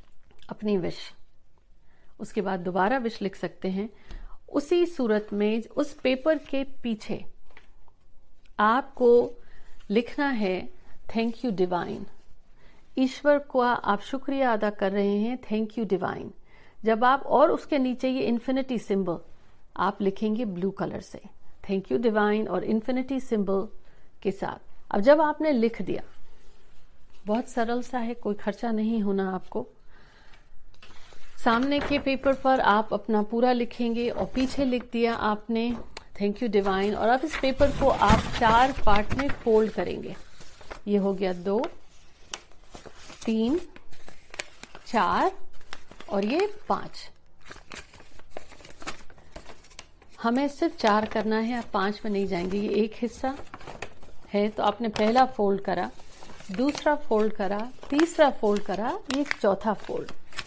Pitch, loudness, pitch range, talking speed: 225 Hz, -26 LUFS, 205-260 Hz, 130 wpm